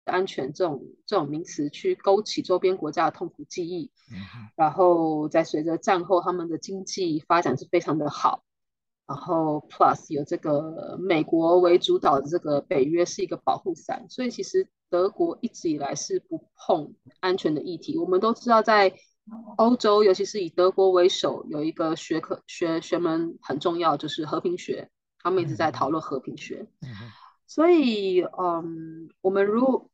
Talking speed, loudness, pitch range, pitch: 260 characters per minute, -24 LUFS, 160-220 Hz, 180 Hz